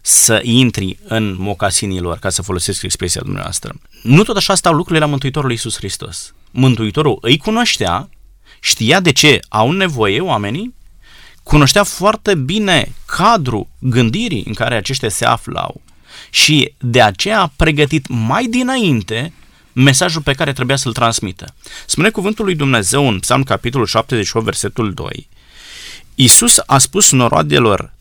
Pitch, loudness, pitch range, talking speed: 130 Hz, -13 LUFS, 110-155 Hz, 140 wpm